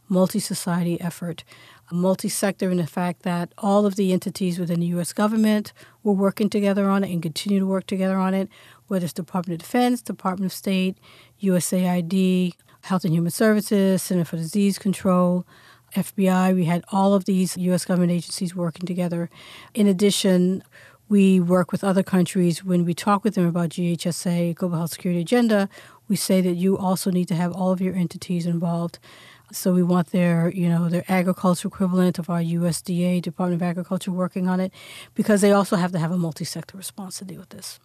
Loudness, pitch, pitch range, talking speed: -22 LUFS, 185 Hz, 175-195 Hz, 185 wpm